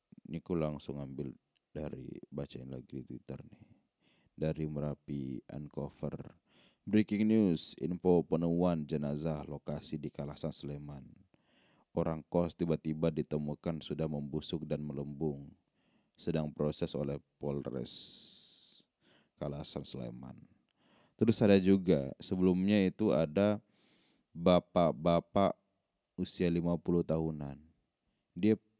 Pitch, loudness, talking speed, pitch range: 80 Hz, -34 LUFS, 100 wpm, 70-85 Hz